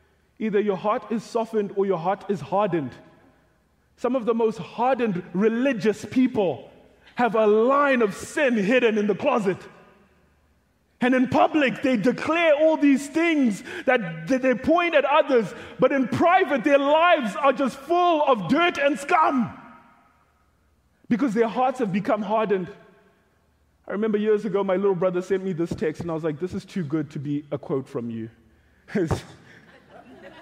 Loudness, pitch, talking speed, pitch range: -23 LUFS, 220 Hz, 160 wpm, 190-270 Hz